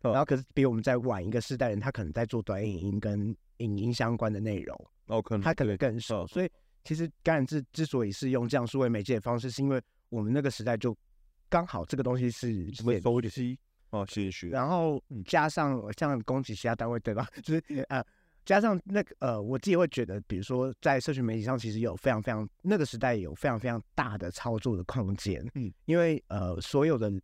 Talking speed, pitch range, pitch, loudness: 320 characters per minute, 110-135 Hz, 120 Hz, -31 LUFS